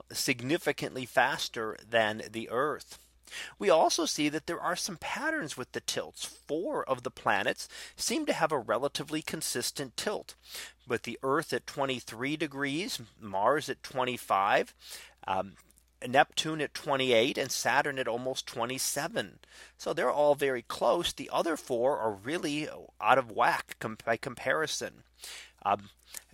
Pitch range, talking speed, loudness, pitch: 115-150 Hz, 140 wpm, -31 LUFS, 135 Hz